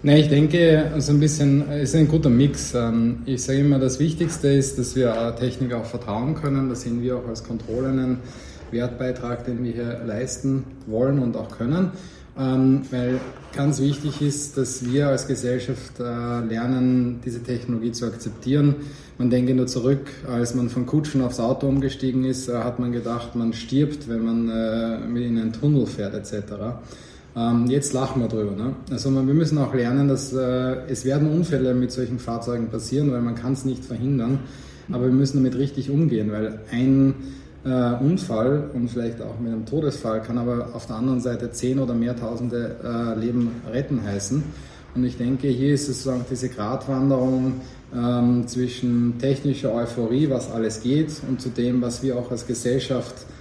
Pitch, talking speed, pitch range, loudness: 125 Hz, 175 wpm, 120-135 Hz, -23 LUFS